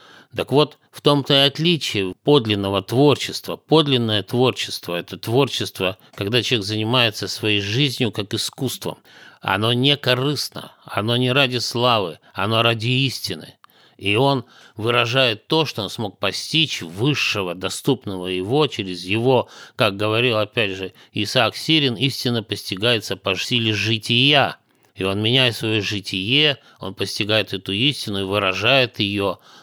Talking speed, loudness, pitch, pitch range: 130 wpm, -19 LUFS, 115 Hz, 100-130 Hz